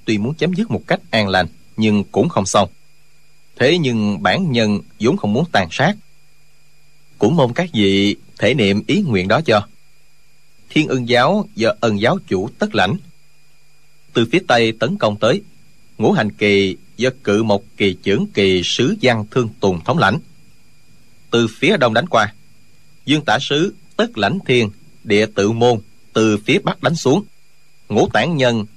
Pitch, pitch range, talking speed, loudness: 125 Hz, 105-150 Hz, 175 wpm, -17 LUFS